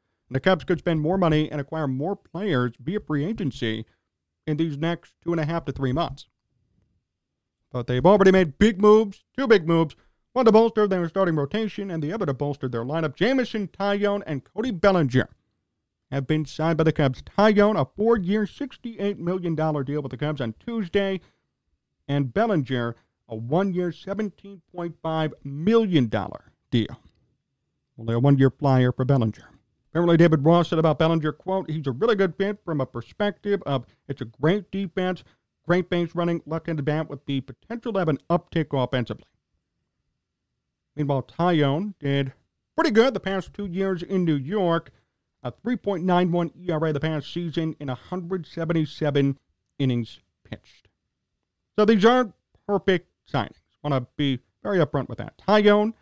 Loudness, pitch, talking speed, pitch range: -24 LUFS, 160 Hz, 165 wpm, 135-195 Hz